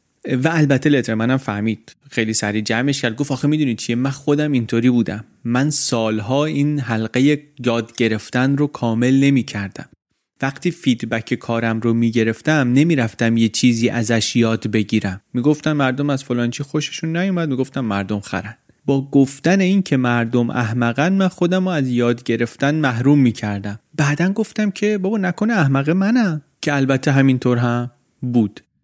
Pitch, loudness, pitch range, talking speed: 130 Hz, -18 LUFS, 115-145 Hz, 160 wpm